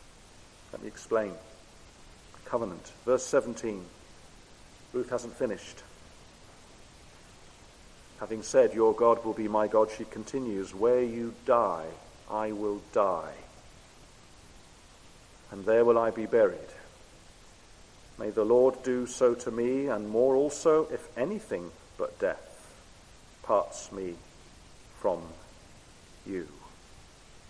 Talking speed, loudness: 105 wpm, -29 LUFS